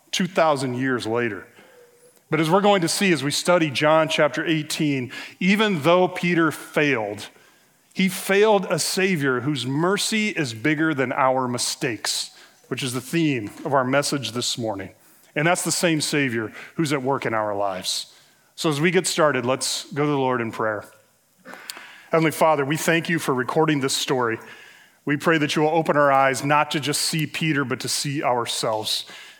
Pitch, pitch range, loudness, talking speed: 150 Hz, 130-165 Hz, -22 LUFS, 180 wpm